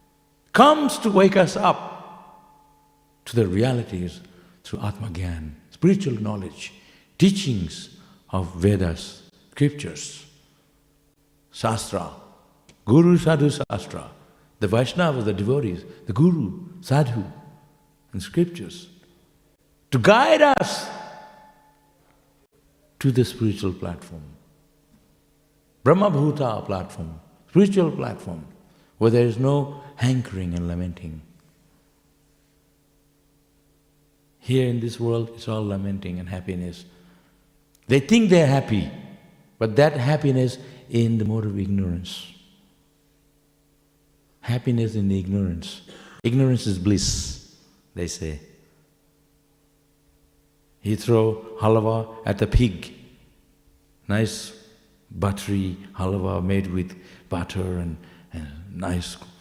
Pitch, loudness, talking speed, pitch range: 125 Hz, -22 LUFS, 95 wpm, 100-145 Hz